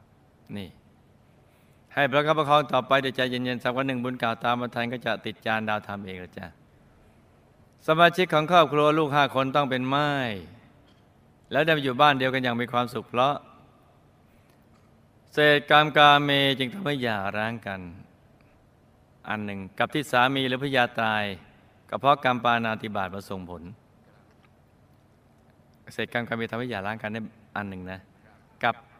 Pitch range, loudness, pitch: 110-140 Hz, -24 LUFS, 120 Hz